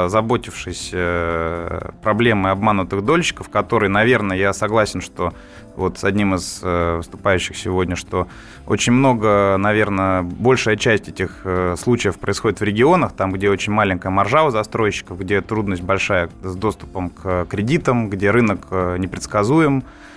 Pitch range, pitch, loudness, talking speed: 90-110 Hz, 95 Hz, -18 LUFS, 135 wpm